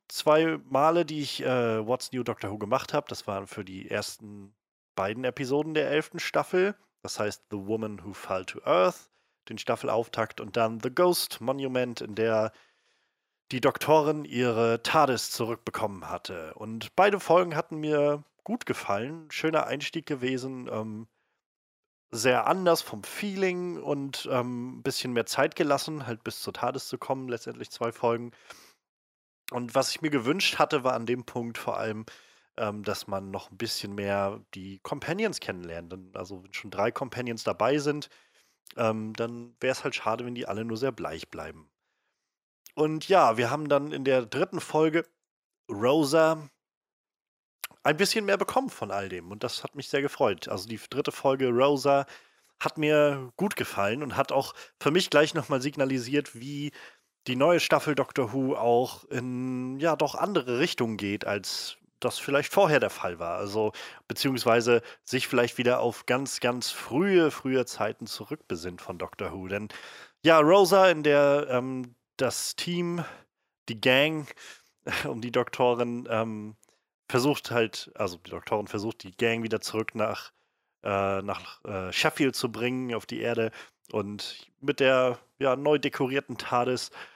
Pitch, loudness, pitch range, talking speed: 125 Hz, -28 LUFS, 110-145 Hz, 160 wpm